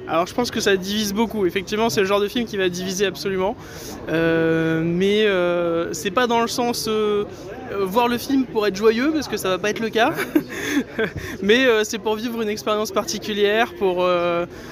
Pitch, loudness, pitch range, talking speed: 210 Hz, -21 LUFS, 185-225 Hz, 205 wpm